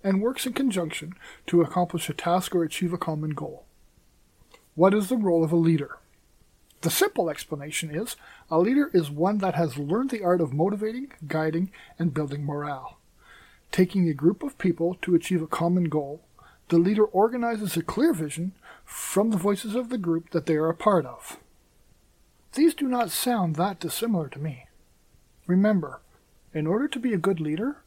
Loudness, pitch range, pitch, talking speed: -26 LUFS, 165-210 Hz, 180 Hz, 180 wpm